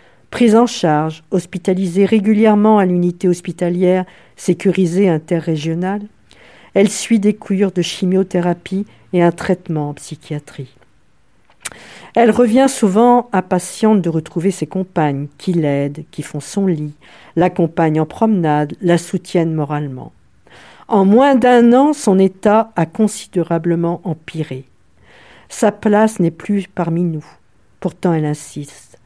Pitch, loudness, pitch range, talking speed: 180 Hz, -15 LUFS, 165-205 Hz, 120 wpm